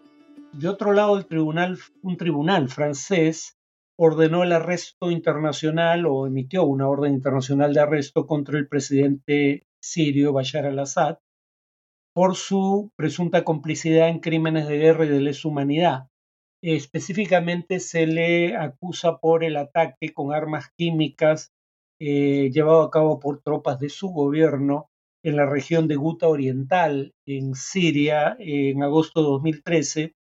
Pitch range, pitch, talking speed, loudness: 145-170 Hz, 155 Hz, 130 wpm, -22 LUFS